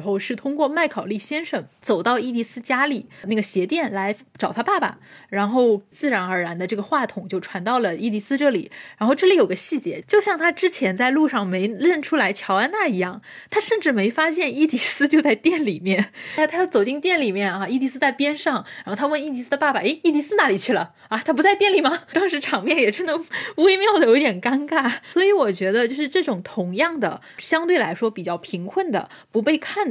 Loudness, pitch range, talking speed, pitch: -21 LUFS, 210-320 Hz, 325 characters per minute, 275 Hz